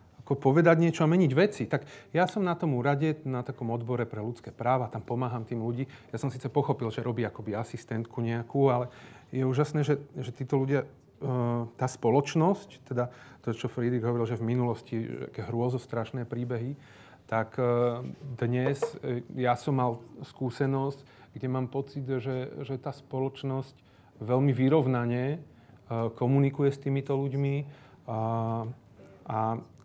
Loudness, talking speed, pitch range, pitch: -30 LUFS, 145 wpm, 120-140 Hz, 130 Hz